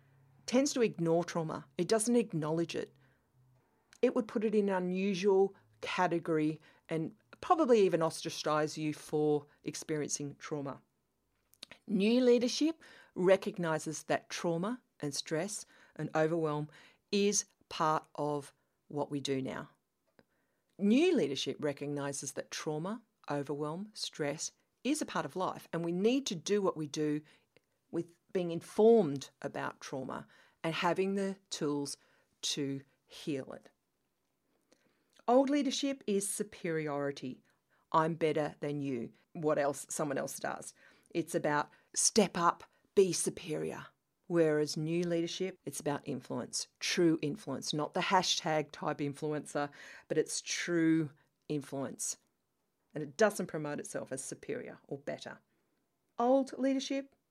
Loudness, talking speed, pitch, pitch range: -34 LUFS, 125 wpm, 165 Hz, 150-200 Hz